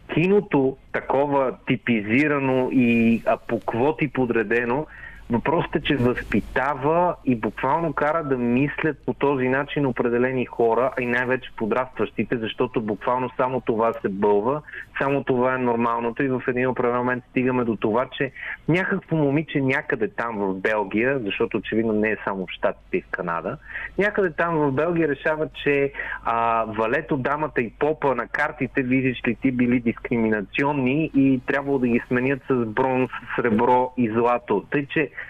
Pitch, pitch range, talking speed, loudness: 130 Hz, 120-145 Hz, 155 wpm, -23 LUFS